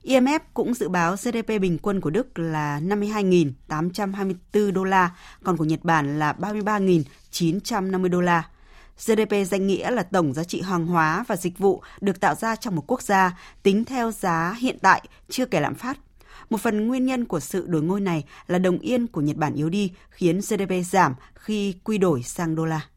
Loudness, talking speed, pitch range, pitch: -23 LUFS, 195 wpm, 170-215 Hz, 190 Hz